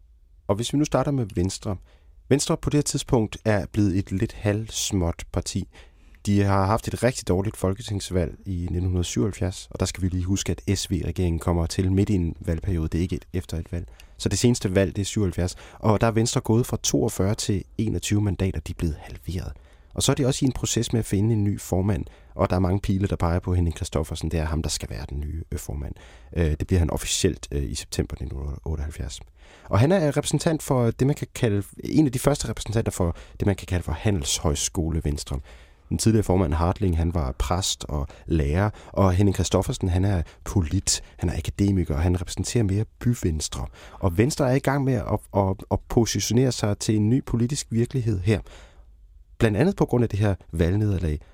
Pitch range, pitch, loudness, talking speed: 85-110 Hz, 95 Hz, -25 LUFS, 210 wpm